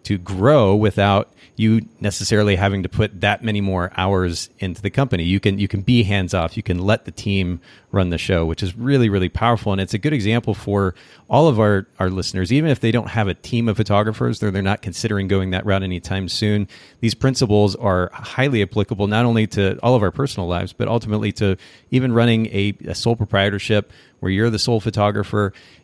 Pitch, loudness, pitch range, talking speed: 105 Hz, -19 LUFS, 95-115 Hz, 210 wpm